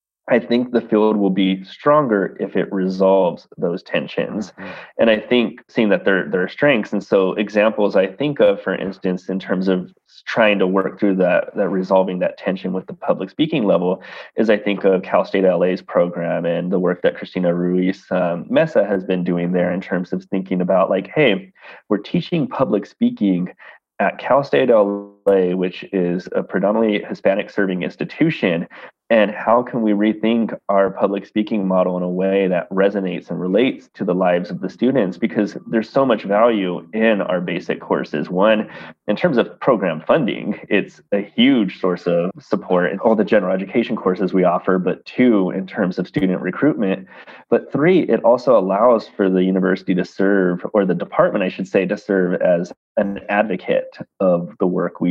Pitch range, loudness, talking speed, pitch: 90-105 Hz, -18 LUFS, 185 wpm, 95 Hz